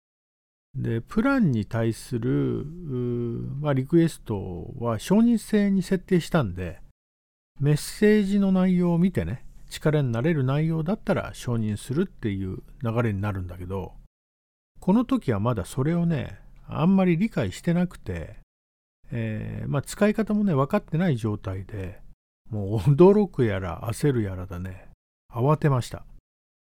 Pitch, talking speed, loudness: 125 Hz, 275 characters per minute, -25 LUFS